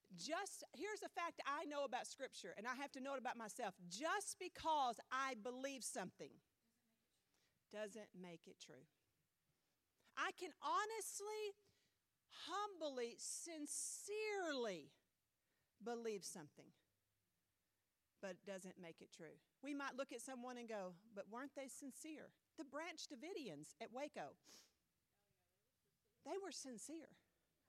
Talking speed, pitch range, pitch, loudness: 125 wpm, 200-330 Hz, 265 Hz, -49 LUFS